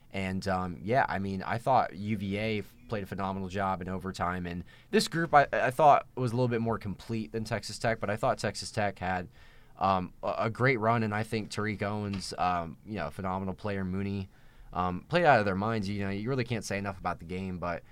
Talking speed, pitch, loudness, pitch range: 225 wpm, 100 Hz, -30 LUFS, 95-115 Hz